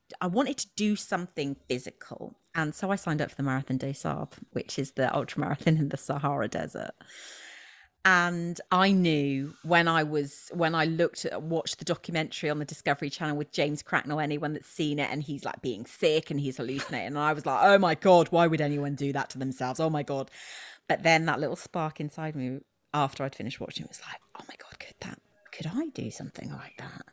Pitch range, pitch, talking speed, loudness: 140-170 Hz, 150 Hz, 215 wpm, -28 LUFS